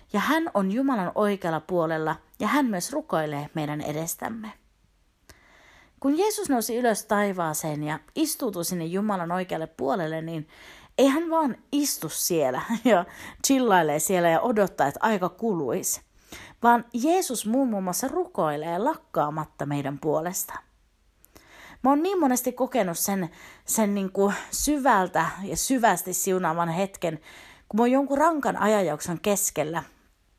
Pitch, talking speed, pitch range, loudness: 200 Hz, 130 wpm, 170-255 Hz, -25 LUFS